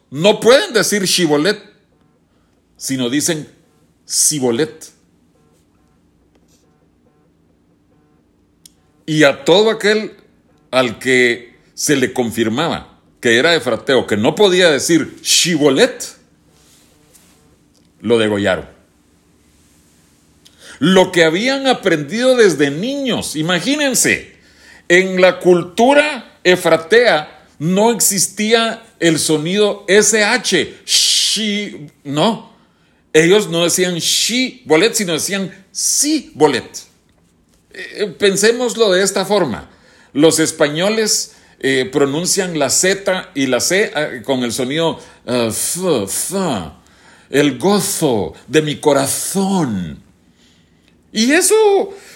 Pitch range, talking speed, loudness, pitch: 125-205 Hz, 95 wpm, -14 LUFS, 165 Hz